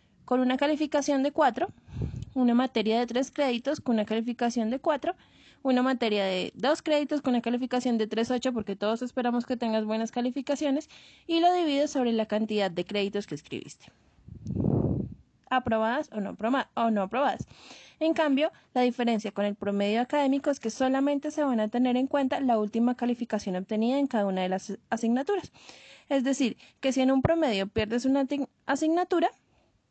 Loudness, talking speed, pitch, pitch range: -28 LUFS, 165 wpm, 250 Hz, 225-280 Hz